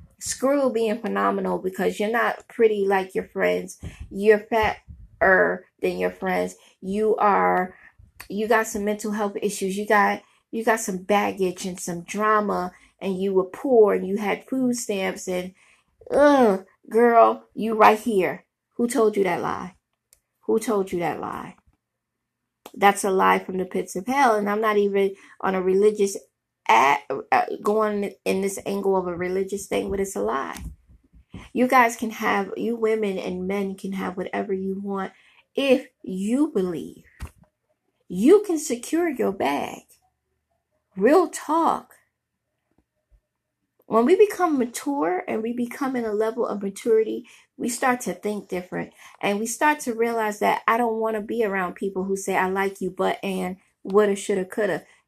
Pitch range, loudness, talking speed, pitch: 190-230 Hz, -23 LUFS, 160 wpm, 210 Hz